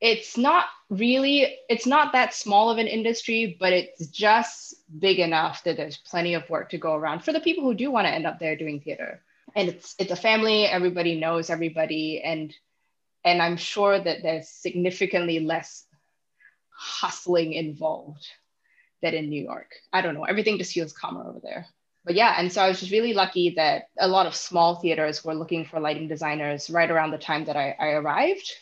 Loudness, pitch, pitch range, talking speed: -24 LUFS, 175 Hz, 160-210 Hz, 195 wpm